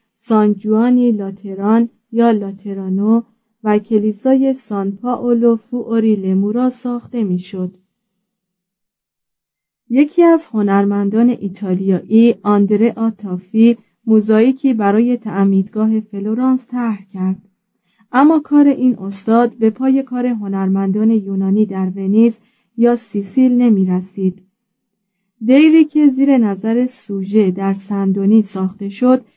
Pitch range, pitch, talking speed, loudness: 195-240 Hz, 220 Hz, 100 wpm, -15 LUFS